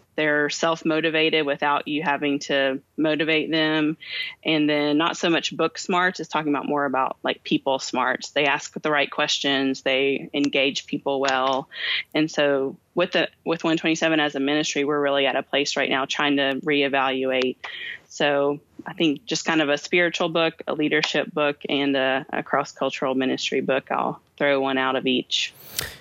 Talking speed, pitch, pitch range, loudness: 175 wpm, 145 Hz, 135-155 Hz, -23 LUFS